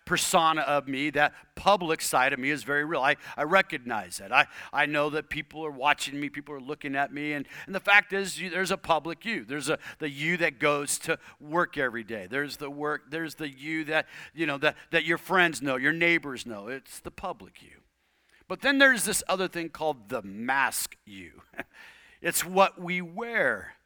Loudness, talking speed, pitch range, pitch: -27 LUFS, 210 wpm, 145-170 Hz, 155 Hz